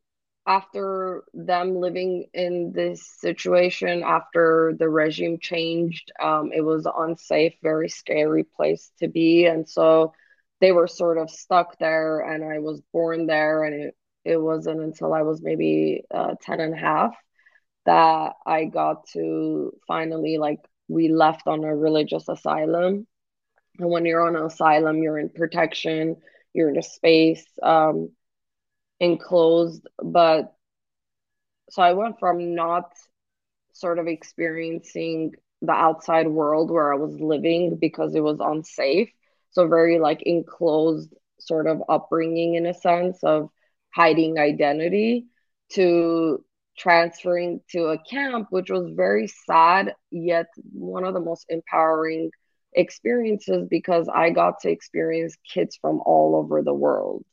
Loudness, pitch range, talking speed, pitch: -22 LUFS, 155-175 Hz, 140 wpm, 165 Hz